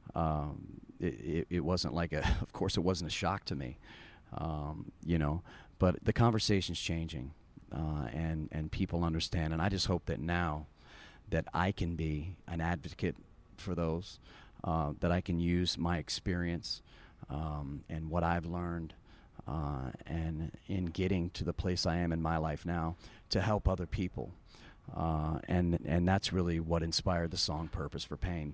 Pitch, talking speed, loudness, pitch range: 85 Hz, 170 wpm, -35 LUFS, 80-90 Hz